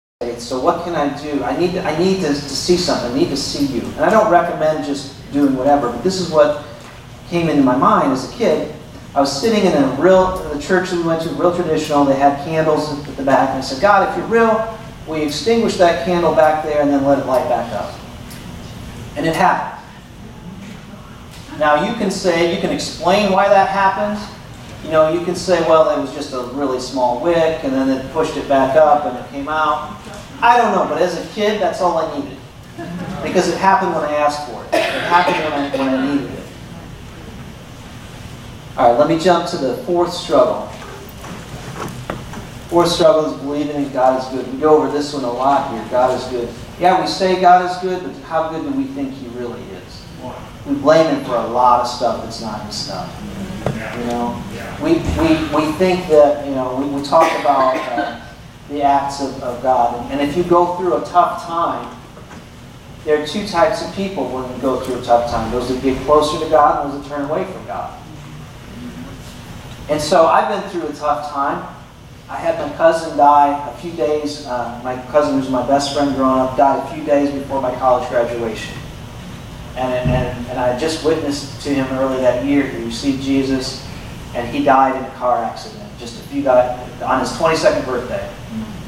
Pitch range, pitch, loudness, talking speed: 130-170 Hz, 145 Hz, -17 LUFS, 210 wpm